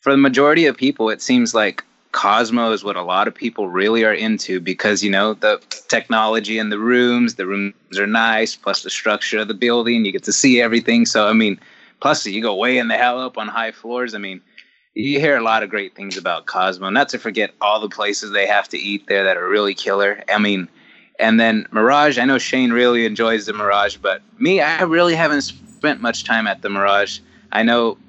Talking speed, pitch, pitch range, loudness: 225 wpm, 115 Hz, 105-125 Hz, -17 LUFS